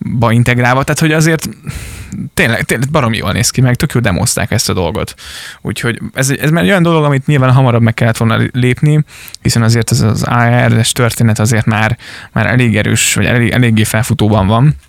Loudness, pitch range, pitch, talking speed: -11 LUFS, 115-135 Hz, 120 Hz, 195 wpm